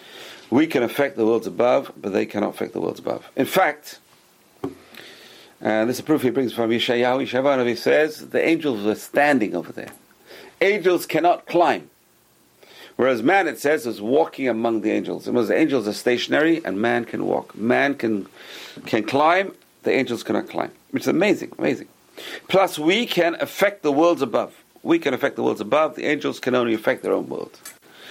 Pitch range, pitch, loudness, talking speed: 115-160 Hz, 130 Hz, -21 LUFS, 190 wpm